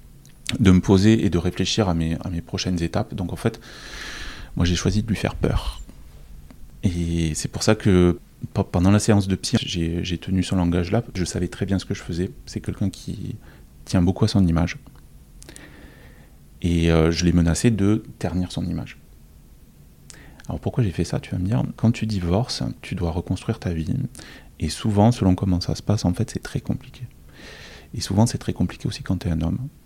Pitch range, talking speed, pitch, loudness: 85-110 Hz, 205 wpm, 95 Hz, -23 LUFS